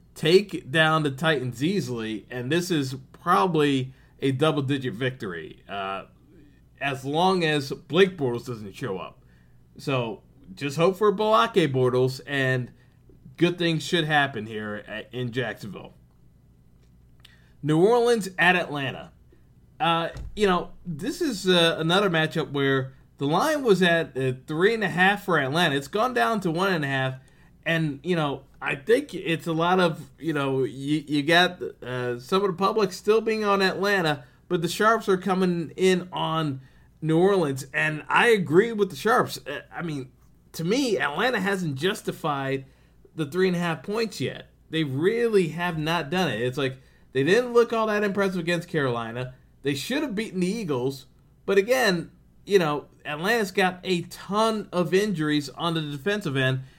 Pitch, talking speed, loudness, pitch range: 160 Hz, 165 wpm, -24 LUFS, 135-190 Hz